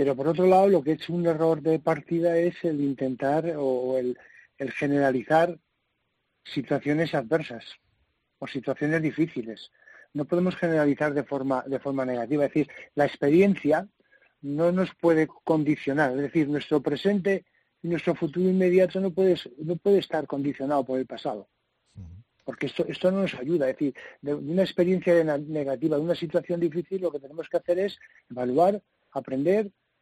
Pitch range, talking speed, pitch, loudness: 140-175 Hz, 160 wpm, 155 Hz, -26 LUFS